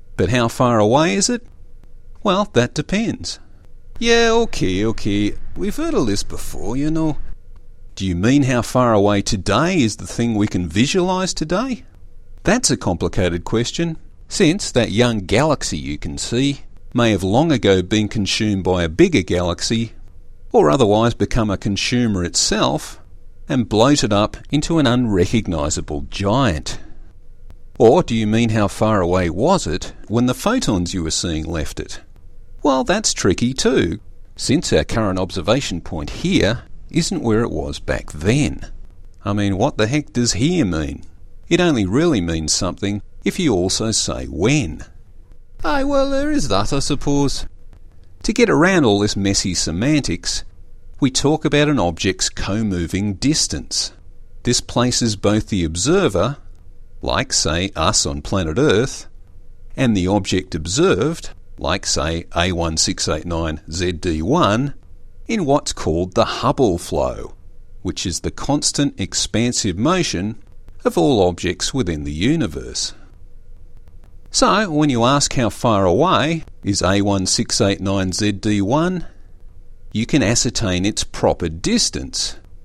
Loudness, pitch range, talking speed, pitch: -18 LUFS, 90-120 Hz, 140 wpm, 100 Hz